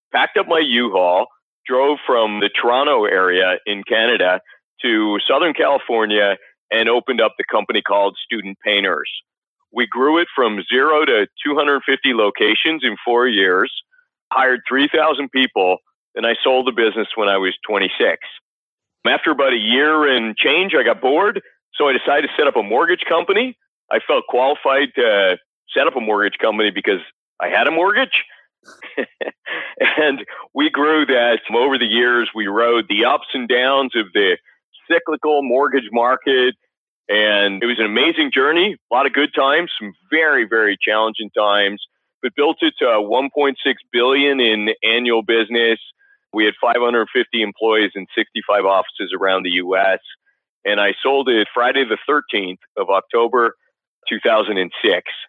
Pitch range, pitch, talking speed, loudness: 110-145 Hz, 120 Hz, 155 wpm, -16 LUFS